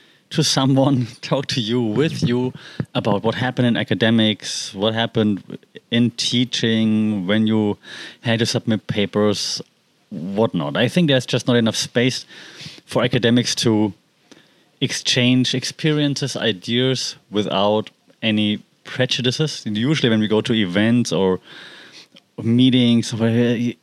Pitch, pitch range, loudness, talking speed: 120 Hz, 110-130 Hz, -19 LUFS, 120 wpm